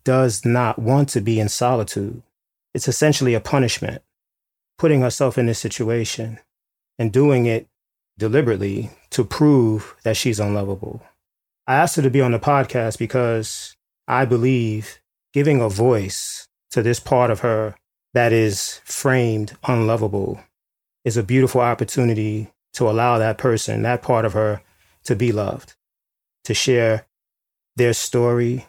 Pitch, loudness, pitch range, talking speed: 115 Hz, -19 LUFS, 110-125 Hz, 140 wpm